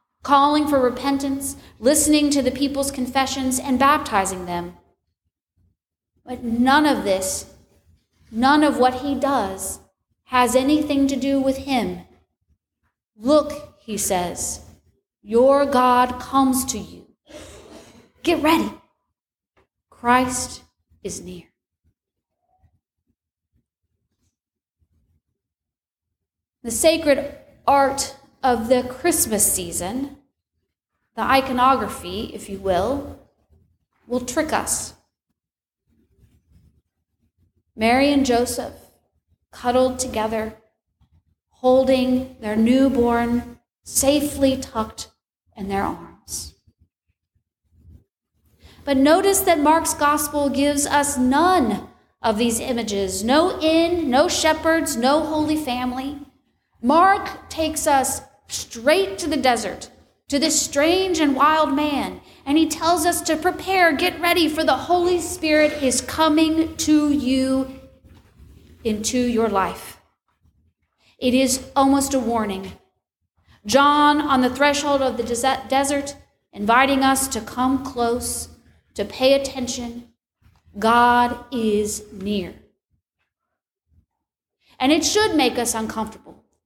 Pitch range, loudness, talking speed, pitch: 200-285 Hz, -20 LUFS, 100 wpm, 255 Hz